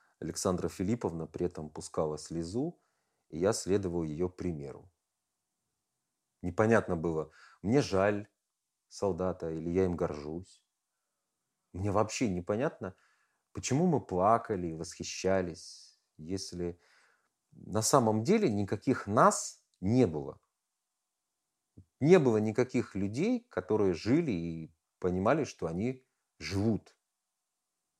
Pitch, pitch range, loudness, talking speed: 95 Hz, 85-110 Hz, -32 LUFS, 100 wpm